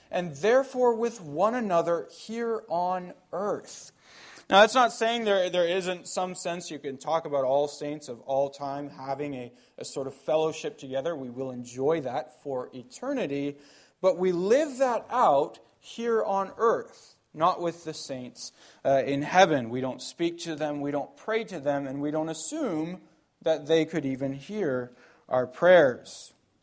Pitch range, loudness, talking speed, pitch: 140-190 Hz, -27 LUFS, 170 wpm, 160 Hz